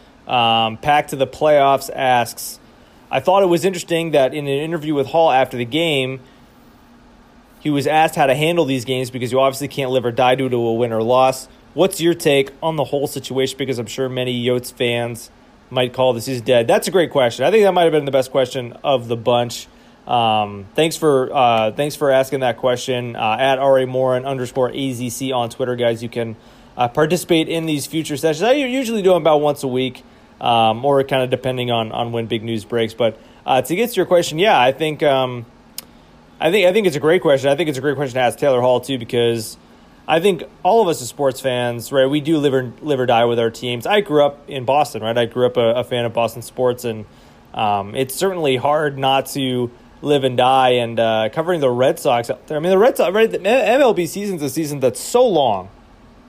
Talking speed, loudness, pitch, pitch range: 235 wpm, -17 LUFS, 130 Hz, 120-150 Hz